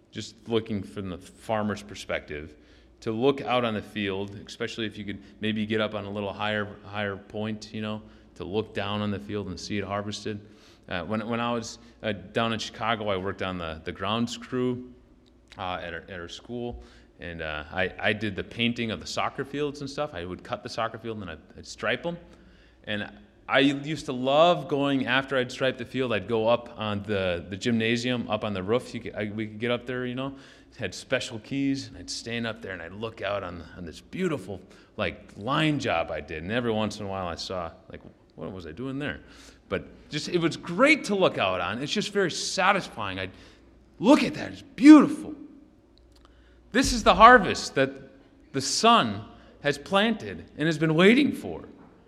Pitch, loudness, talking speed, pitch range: 110 Hz, -26 LUFS, 215 wpm, 100-135 Hz